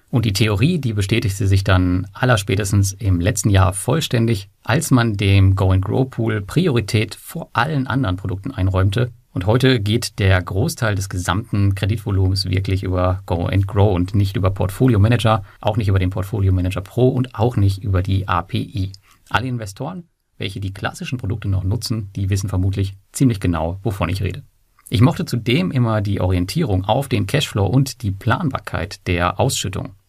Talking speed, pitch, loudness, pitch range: 160 wpm, 105 Hz, -19 LUFS, 95-120 Hz